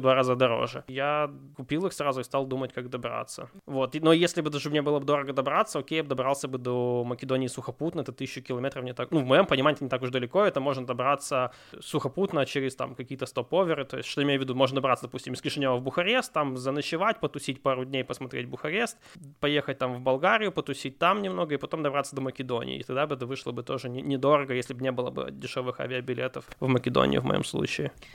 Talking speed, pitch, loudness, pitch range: 225 wpm, 135 Hz, -28 LUFS, 130-145 Hz